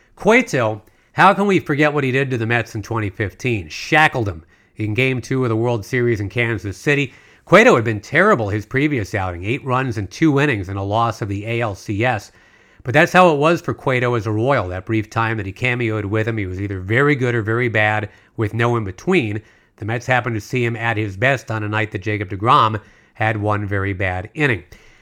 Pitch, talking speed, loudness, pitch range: 115 Hz, 225 wpm, -18 LUFS, 105-130 Hz